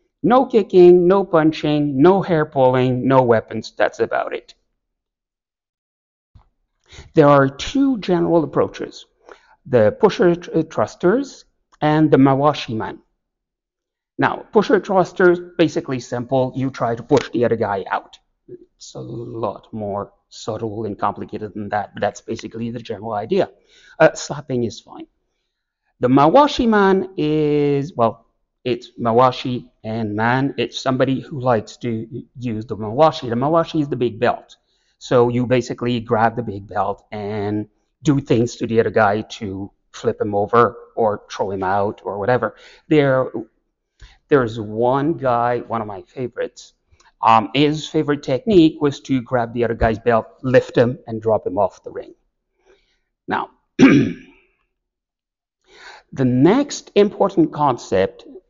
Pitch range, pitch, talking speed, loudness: 115-160 Hz, 130 Hz, 140 wpm, -18 LUFS